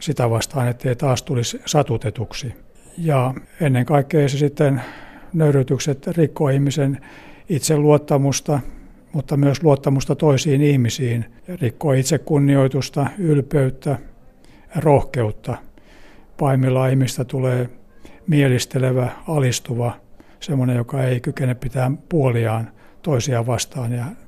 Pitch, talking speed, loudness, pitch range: 135 Hz, 95 wpm, -19 LUFS, 125-145 Hz